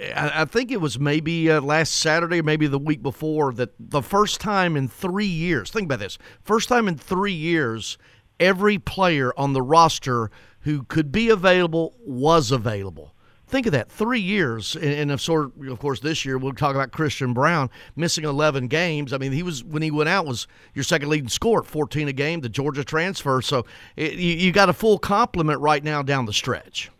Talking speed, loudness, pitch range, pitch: 190 wpm, -22 LUFS, 135-170 Hz, 150 Hz